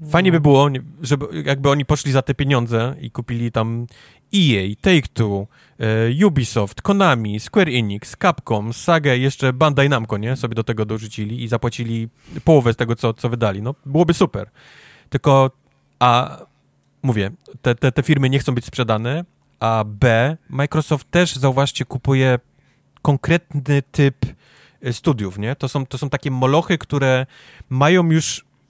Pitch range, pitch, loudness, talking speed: 115-145 Hz, 130 Hz, -18 LUFS, 150 wpm